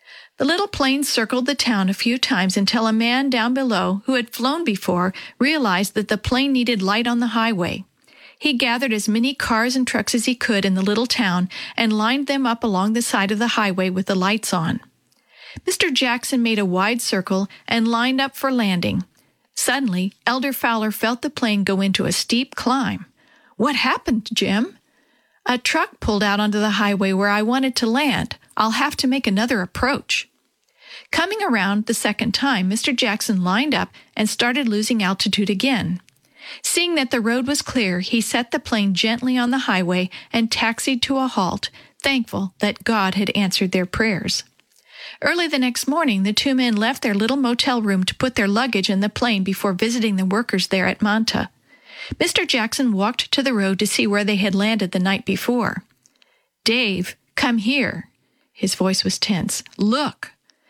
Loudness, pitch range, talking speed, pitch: -20 LUFS, 200-255 Hz, 185 wpm, 225 Hz